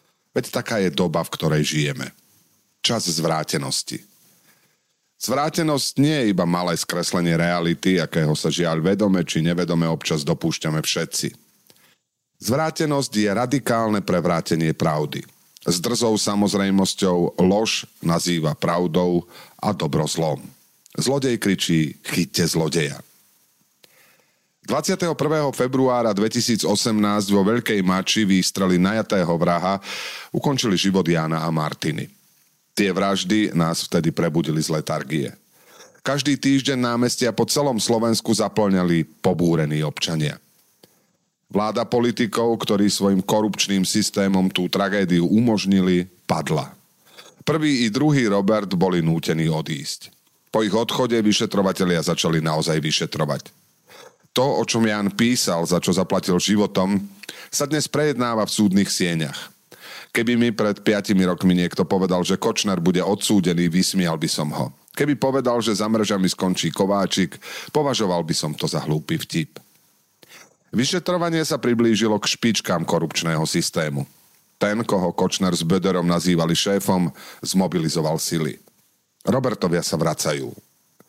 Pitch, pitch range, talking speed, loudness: 100 Hz, 85-115 Hz, 120 wpm, -21 LUFS